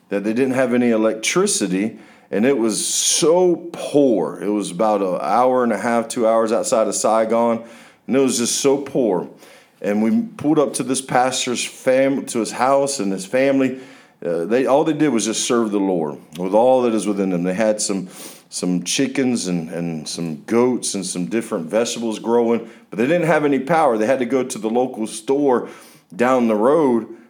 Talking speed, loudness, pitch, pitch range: 200 wpm, -19 LUFS, 115 Hz, 105-130 Hz